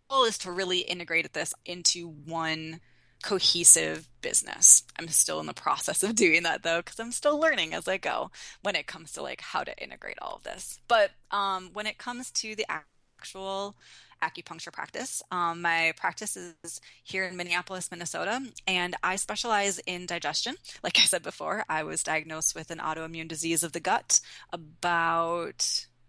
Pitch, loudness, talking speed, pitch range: 175 Hz, -26 LUFS, 175 wpm, 165-195 Hz